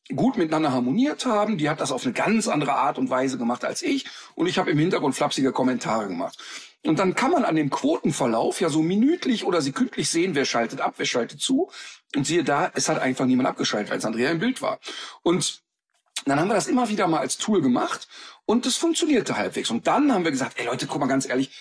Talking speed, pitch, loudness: 230 wpm, 170 Hz, -23 LUFS